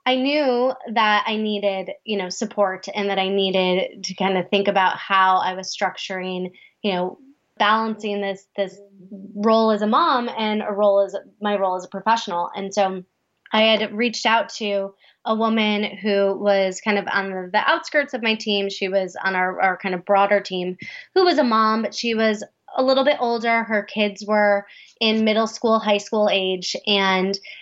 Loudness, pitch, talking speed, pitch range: -21 LUFS, 205 Hz, 190 wpm, 195-220 Hz